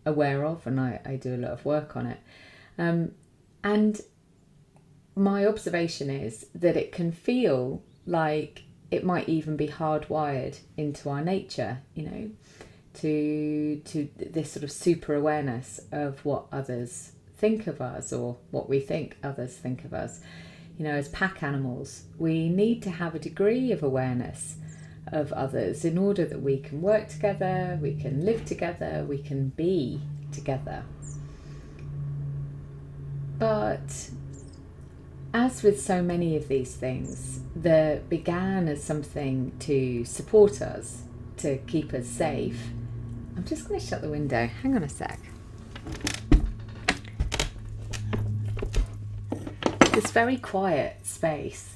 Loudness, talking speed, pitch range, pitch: -29 LUFS, 135 wpm, 125-160 Hz, 145 Hz